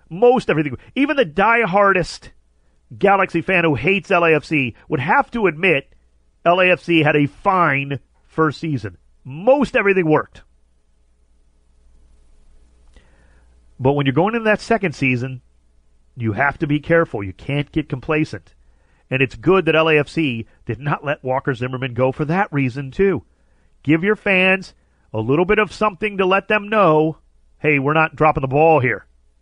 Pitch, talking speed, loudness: 145 Hz, 150 wpm, -17 LUFS